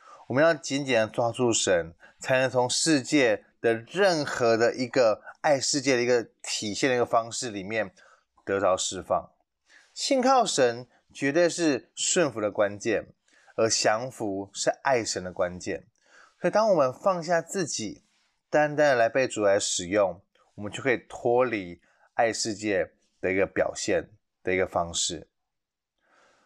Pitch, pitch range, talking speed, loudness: 125 Hz, 110-150 Hz, 220 characters per minute, -26 LUFS